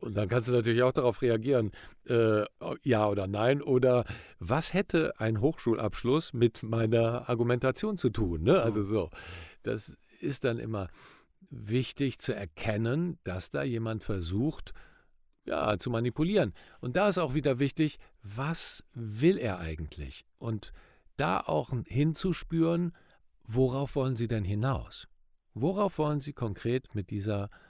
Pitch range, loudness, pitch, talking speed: 105-140 Hz, -30 LUFS, 120 Hz, 140 wpm